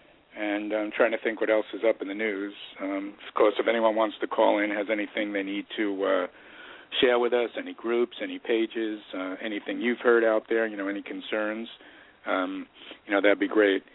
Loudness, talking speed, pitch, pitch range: -27 LUFS, 215 wpm, 110 Hz, 100-120 Hz